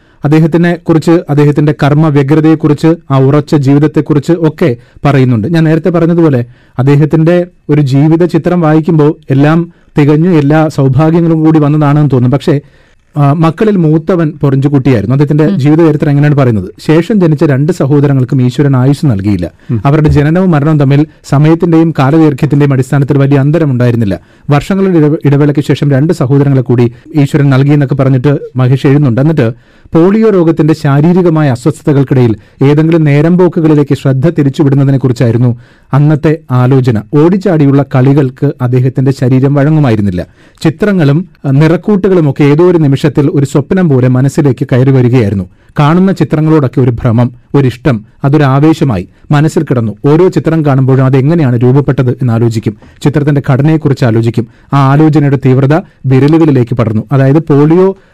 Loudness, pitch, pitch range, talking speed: -8 LUFS, 145 Hz, 135-160 Hz, 120 wpm